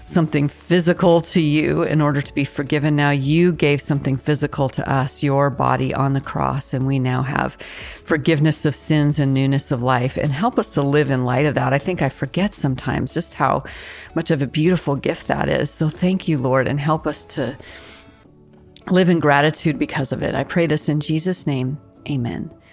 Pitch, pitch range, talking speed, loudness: 145 Hz, 135-160 Hz, 200 wpm, -19 LUFS